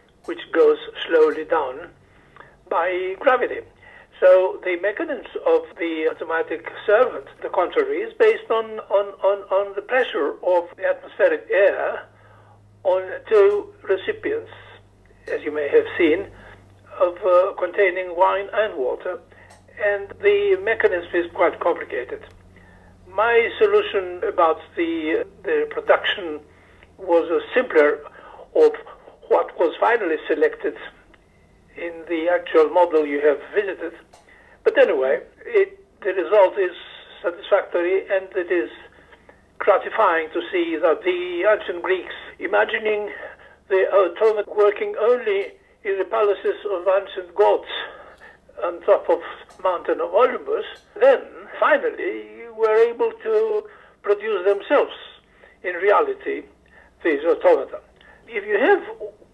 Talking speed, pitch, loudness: 120 wpm, 395 Hz, -21 LUFS